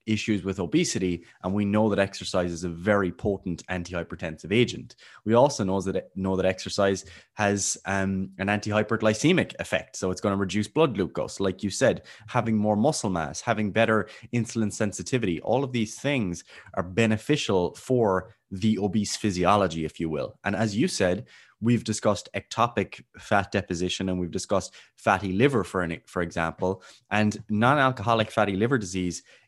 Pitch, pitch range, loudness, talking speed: 100 Hz, 95-110 Hz, -26 LUFS, 165 wpm